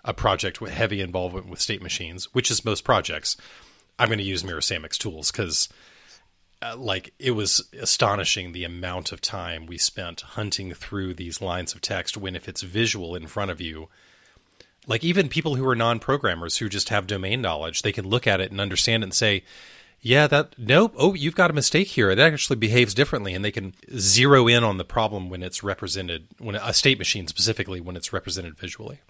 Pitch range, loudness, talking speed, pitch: 90-120 Hz, -23 LUFS, 200 wpm, 100 Hz